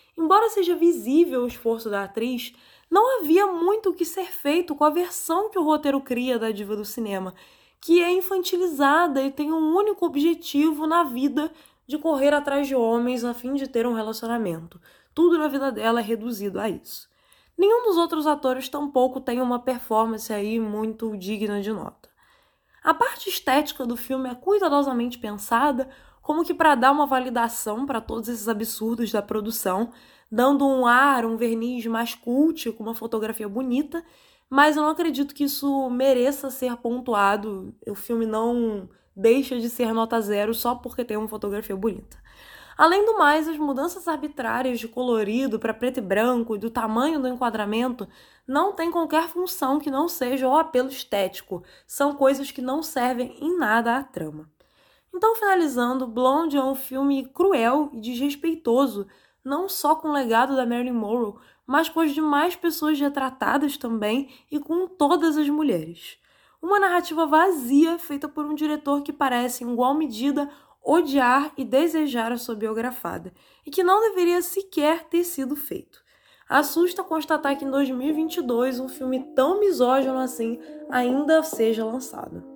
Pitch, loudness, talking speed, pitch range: 270 Hz, -23 LUFS, 165 wpm, 235-310 Hz